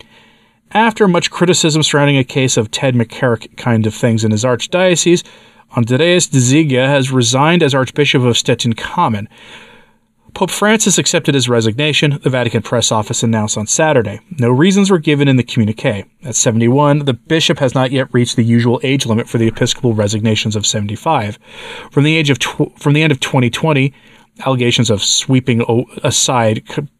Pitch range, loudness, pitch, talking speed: 115-150 Hz, -13 LUFS, 130 Hz, 175 wpm